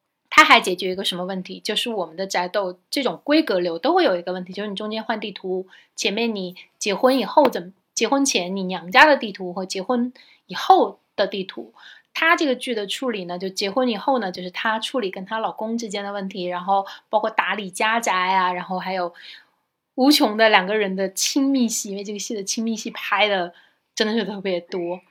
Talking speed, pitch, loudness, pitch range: 315 characters per minute, 205 Hz, -21 LUFS, 185-235 Hz